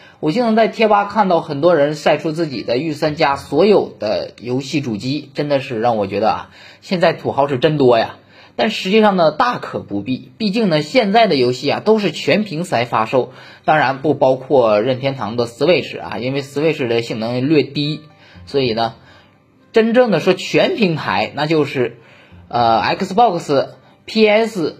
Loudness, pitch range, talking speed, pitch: -16 LUFS, 125-185 Hz, 280 characters per minute, 145 Hz